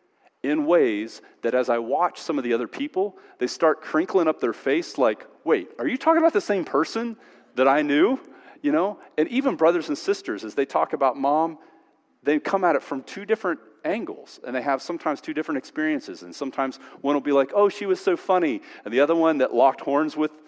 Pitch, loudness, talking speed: 175 Hz, -24 LUFS, 220 wpm